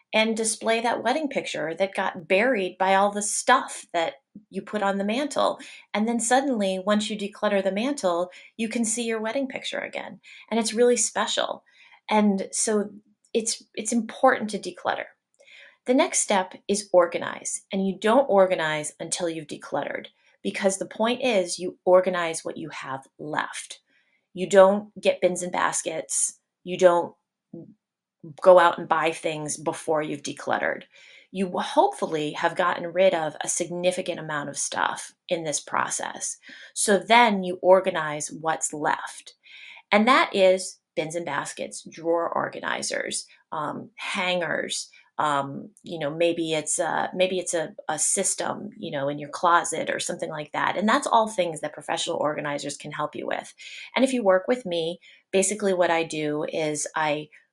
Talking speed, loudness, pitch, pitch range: 165 wpm, -24 LUFS, 185 Hz, 170-210 Hz